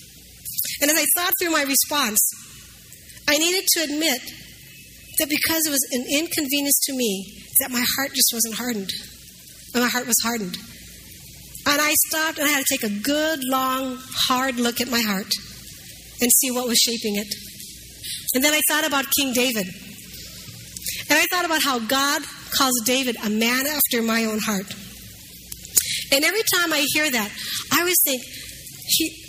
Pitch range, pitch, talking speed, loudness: 235-300 Hz, 270 Hz, 170 wpm, -20 LUFS